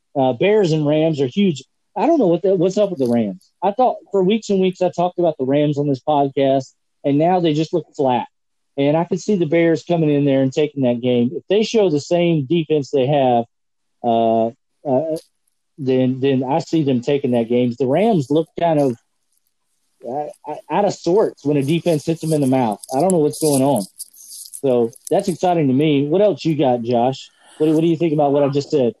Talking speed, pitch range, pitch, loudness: 230 wpm, 135-170 Hz, 150 Hz, -18 LUFS